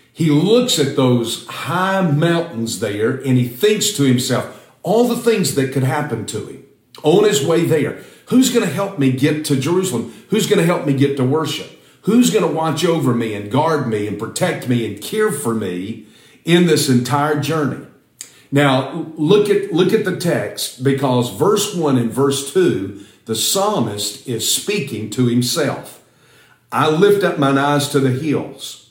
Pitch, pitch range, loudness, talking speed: 145 Hz, 125-180 Hz, -17 LUFS, 180 wpm